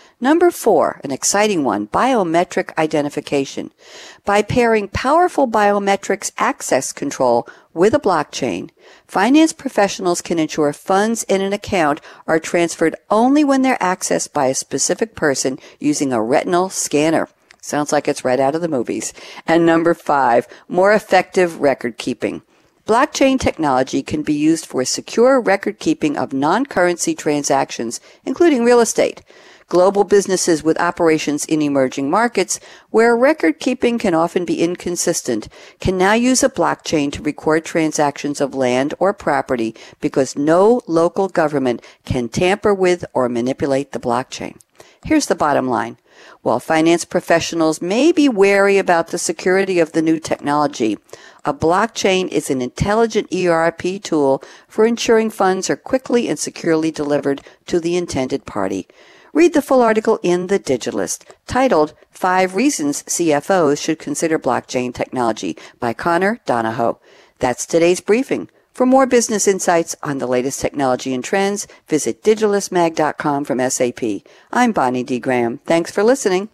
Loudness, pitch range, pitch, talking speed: -17 LUFS, 150-210 Hz, 175 Hz, 145 wpm